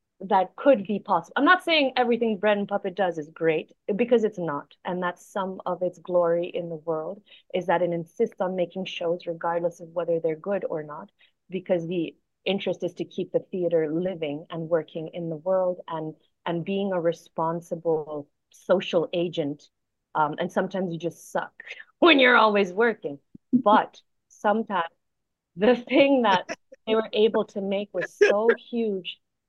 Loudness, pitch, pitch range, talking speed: -25 LUFS, 180 Hz, 165-210 Hz, 170 wpm